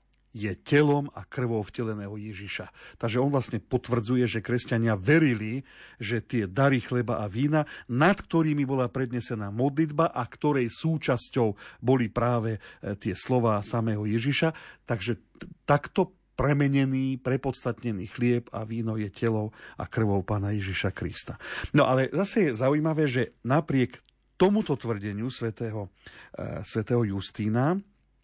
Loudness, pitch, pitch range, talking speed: -27 LUFS, 120 Hz, 110-140 Hz, 130 wpm